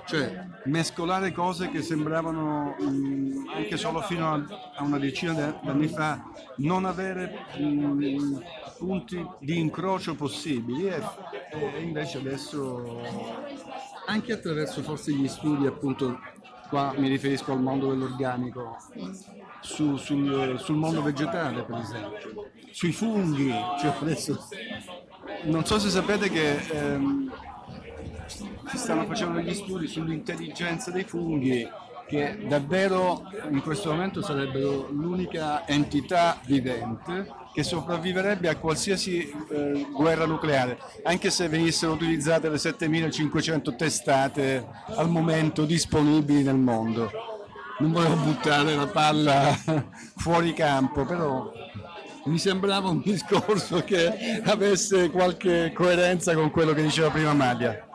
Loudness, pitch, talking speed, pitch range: -26 LUFS, 155 Hz, 115 wpm, 140-175 Hz